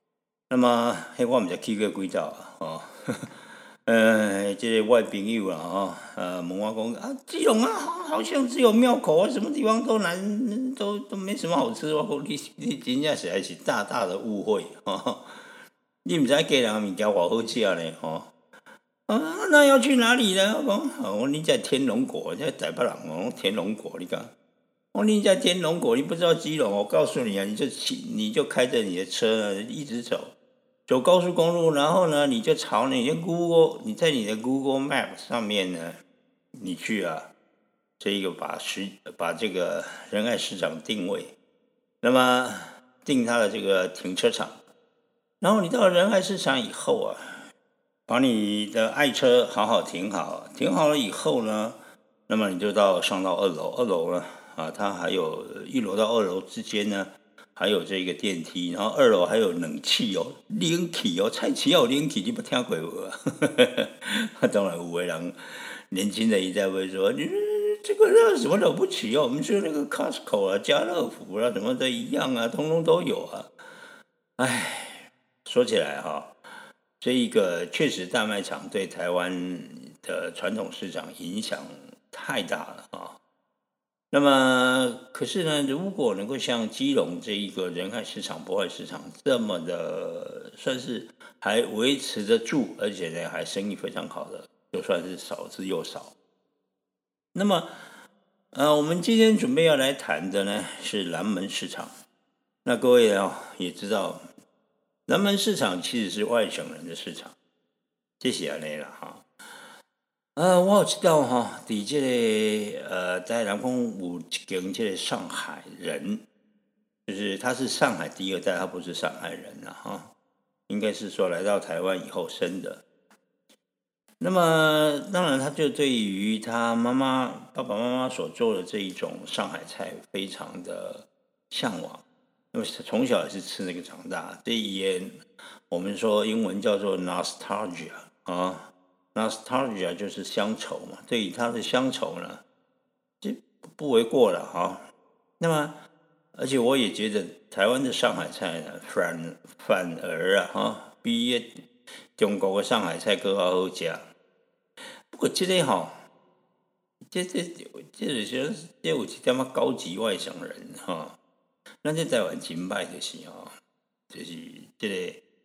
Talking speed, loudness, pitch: 240 characters per minute, -26 LUFS, 215 Hz